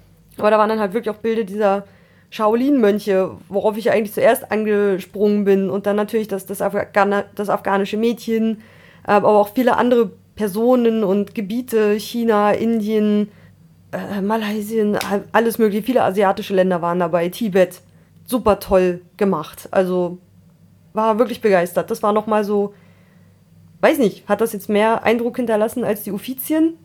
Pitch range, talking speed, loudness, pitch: 200-225 Hz, 145 wpm, -18 LUFS, 210 Hz